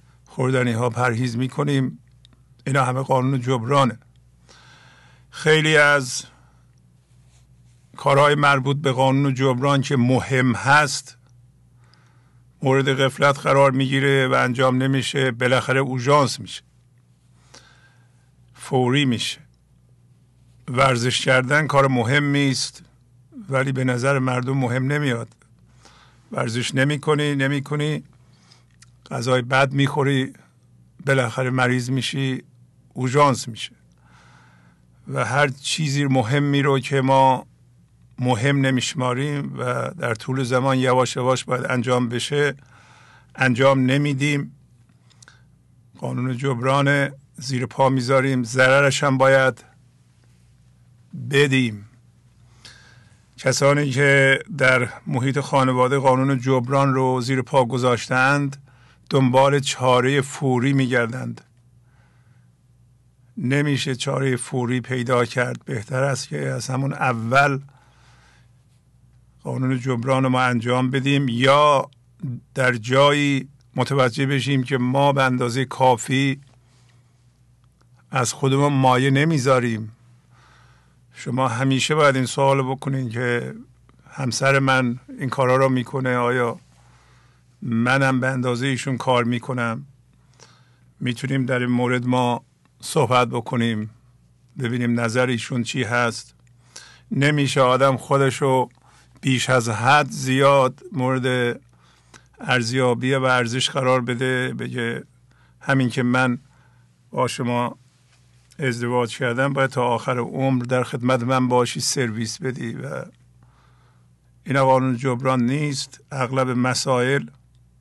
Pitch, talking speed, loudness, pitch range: 130 Hz, 100 wpm, -20 LUFS, 125-135 Hz